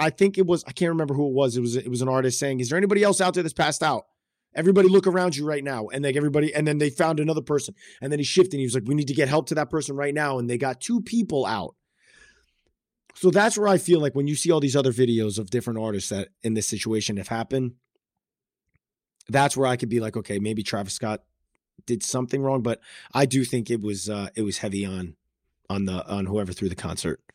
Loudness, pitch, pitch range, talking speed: -24 LUFS, 135 Hz, 110-155 Hz, 260 wpm